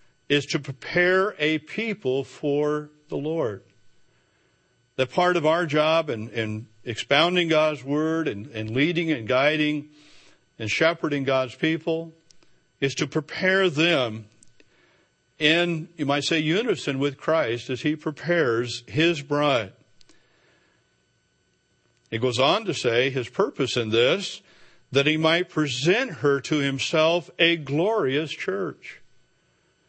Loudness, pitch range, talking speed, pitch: -24 LUFS, 130-165 Hz, 120 wpm, 150 Hz